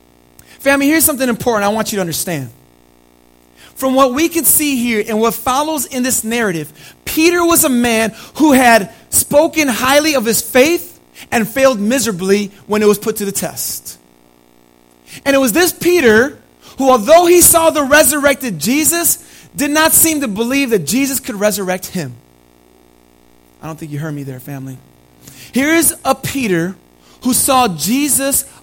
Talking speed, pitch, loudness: 165 wpm, 230 Hz, -13 LUFS